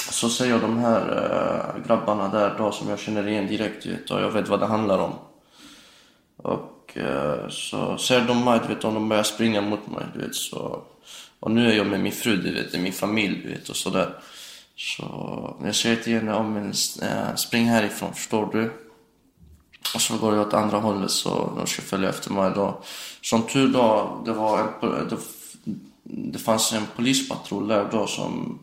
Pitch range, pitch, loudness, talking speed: 105-115 Hz, 110 Hz, -24 LUFS, 195 wpm